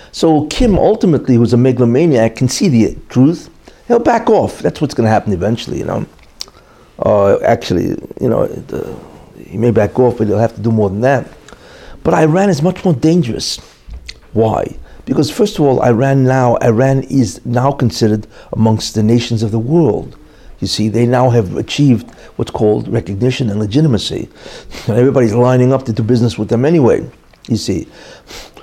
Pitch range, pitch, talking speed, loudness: 110-135 Hz, 120 Hz, 175 wpm, -13 LUFS